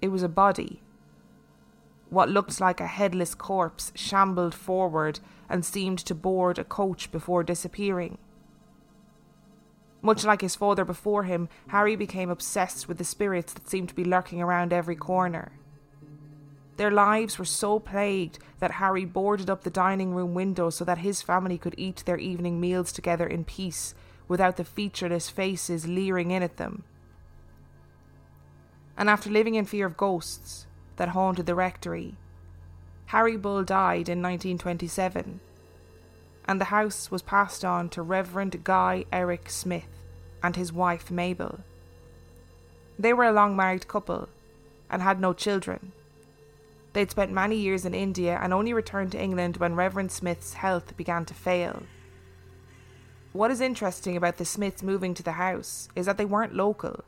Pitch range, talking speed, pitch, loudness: 155-195 Hz, 155 wpm, 180 Hz, -27 LUFS